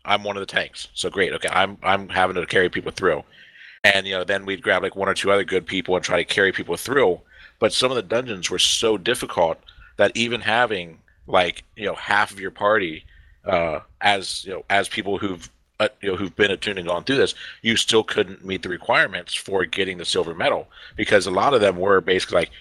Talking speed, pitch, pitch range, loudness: 235 wpm, 100 Hz, 90-110 Hz, -21 LUFS